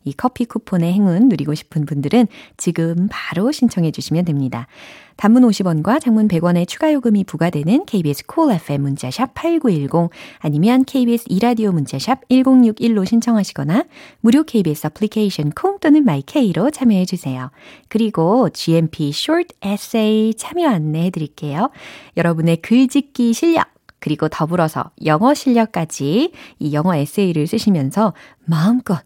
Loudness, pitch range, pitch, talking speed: -17 LUFS, 160-250 Hz, 205 Hz, 340 characters per minute